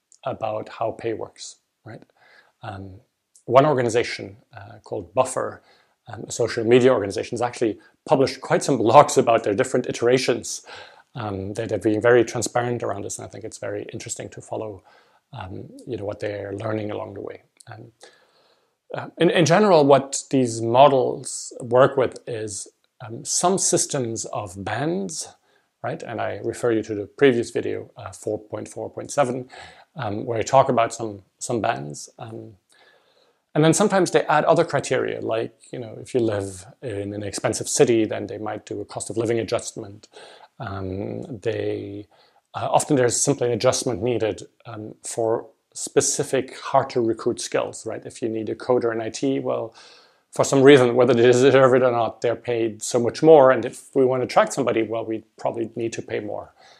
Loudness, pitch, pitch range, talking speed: -21 LUFS, 115 Hz, 110-130 Hz, 175 wpm